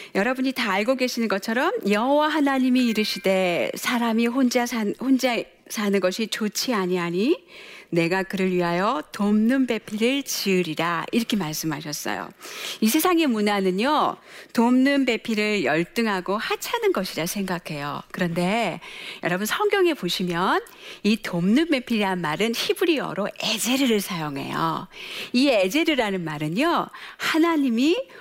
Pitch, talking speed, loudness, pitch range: 220 Hz, 300 characters per minute, -23 LUFS, 190-265 Hz